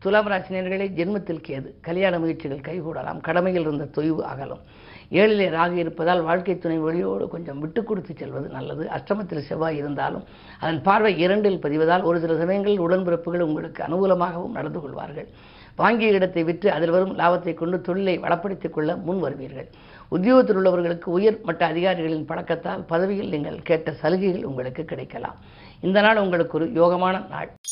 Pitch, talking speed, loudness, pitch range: 175 Hz, 145 wpm, -23 LUFS, 160-190 Hz